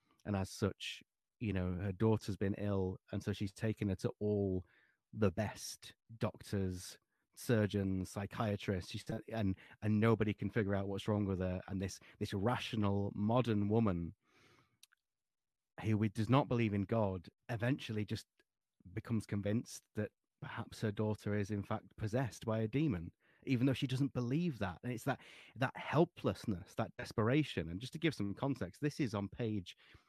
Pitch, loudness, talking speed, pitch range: 105 Hz, -38 LUFS, 165 wpm, 100-120 Hz